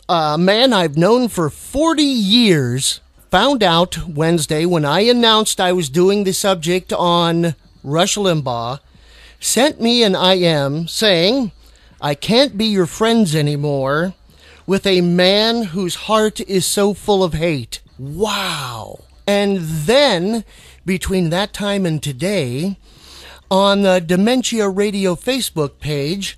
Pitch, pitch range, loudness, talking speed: 185 Hz, 165-205 Hz, -16 LUFS, 125 wpm